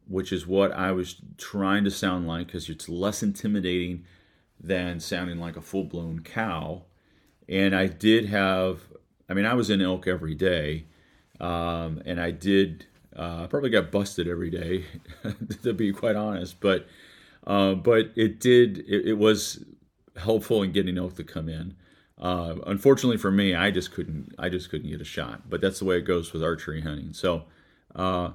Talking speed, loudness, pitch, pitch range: 180 wpm, -26 LUFS, 90 Hz, 85-100 Hz